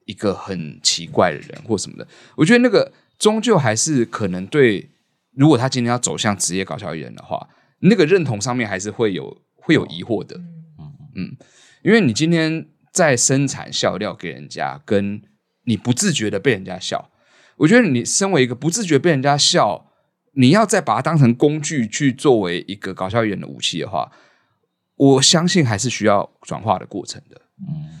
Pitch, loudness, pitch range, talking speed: 140 Hz, -17 LUFS, 110-160 Hz, 280 characters per minute